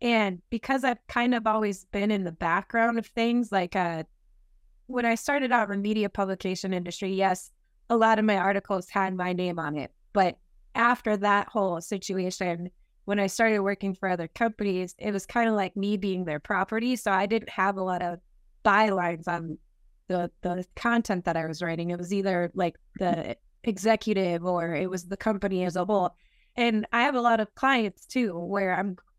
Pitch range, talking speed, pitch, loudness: 180-225 Hz, 195 wpm, 195 Hz, -27 LUFS